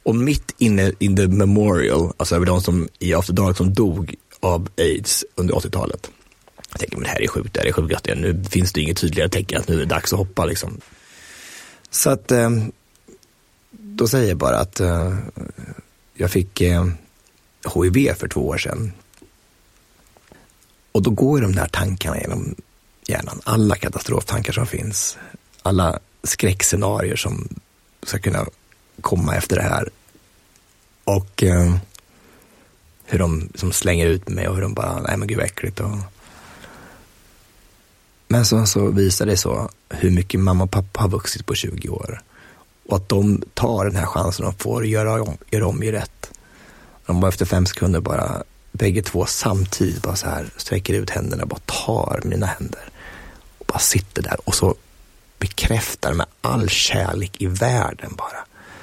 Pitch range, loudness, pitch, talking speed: 90-110 Hz, -20 LUFS, 95 Hz, 165 wpm